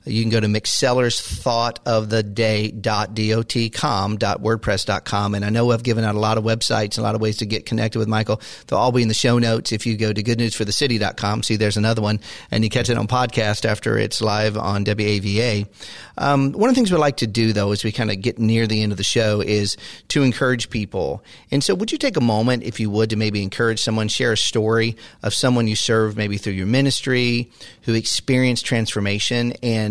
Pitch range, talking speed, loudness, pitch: 105-120 Hz, 210 wpm, -20 LUFS, 110 Hz